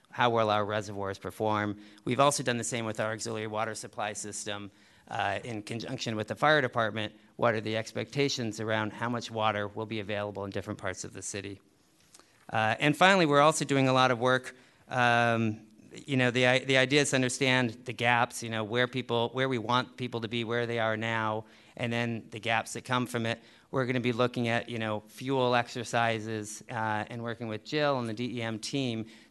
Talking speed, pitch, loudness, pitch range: 210 wpm, 115 Hz, -29 LUFS, 110-125 Hz